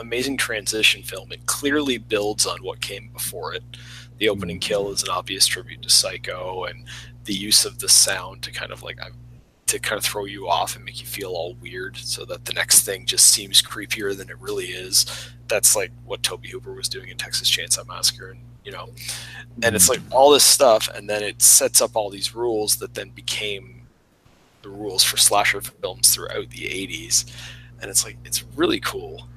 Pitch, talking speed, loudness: 110 Hz, 200 wpm, -19 LUFS